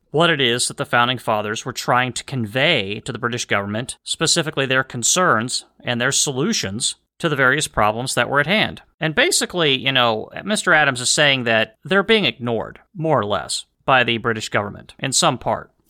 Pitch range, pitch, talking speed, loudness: 115-155 Hz, 130 Hz, 195 wpm, -18 LUFS